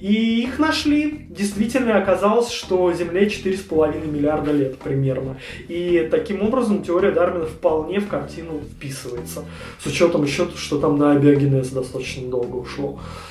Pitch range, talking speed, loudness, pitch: 140-205 Hz, 135 wpm, -20 LUFS, 170 Hz